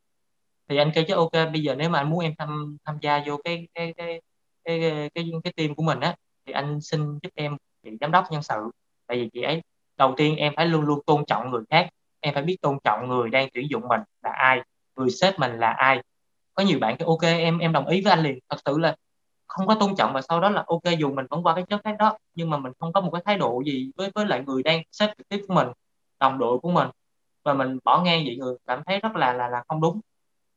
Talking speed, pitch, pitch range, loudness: 270 wpm, 155 Hz, 135-170 Hz, -24 LUFS